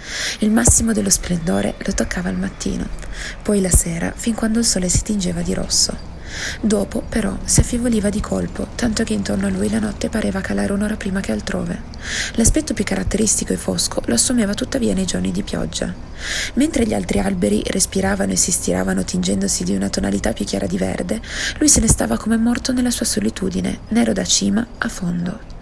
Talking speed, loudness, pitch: 185 wpm, -18 LUFS, 200 Hz